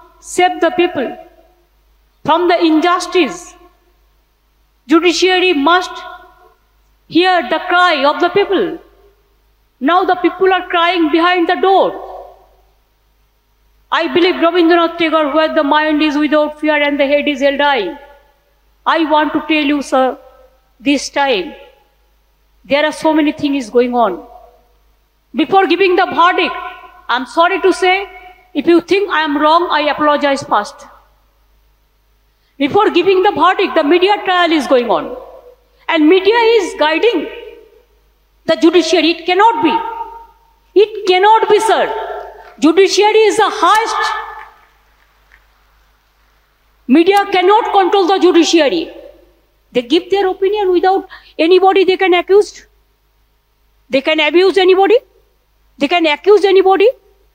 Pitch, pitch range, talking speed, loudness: 350 Hz, 310-385 Hz, 125 wpm, -12 LUFS